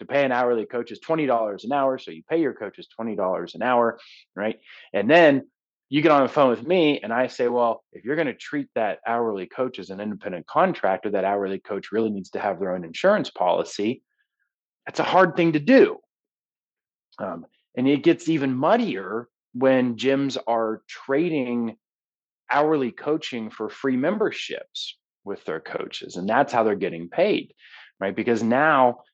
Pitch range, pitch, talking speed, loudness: 115-140 Hz, 125 Hz, 180 wpm, -23 LUFS